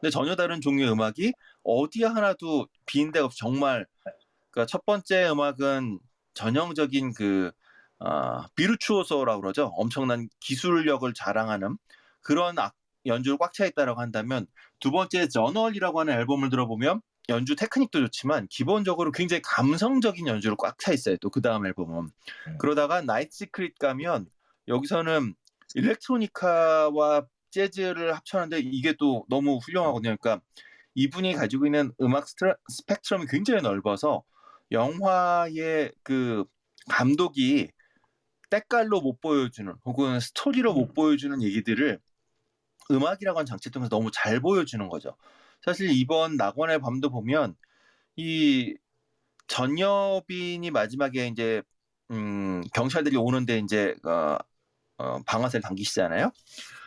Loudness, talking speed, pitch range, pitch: -26 LUFS, 310 characters per minute, 120-180 Hz, 145 Hz